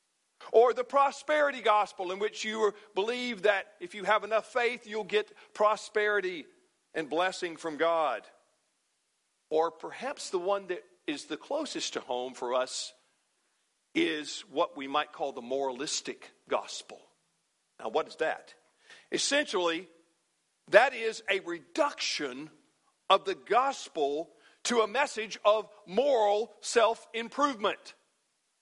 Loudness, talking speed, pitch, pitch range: -30 LUFS, 125 wpm, 215 Hz, 180-275 Hz